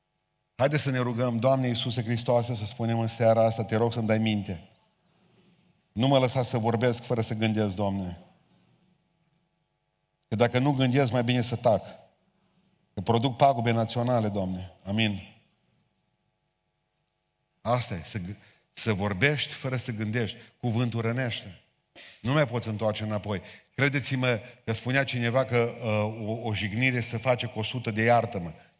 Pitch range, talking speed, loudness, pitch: 110-130 Hz, 150 wpm, -27 LUFS, 120 Hz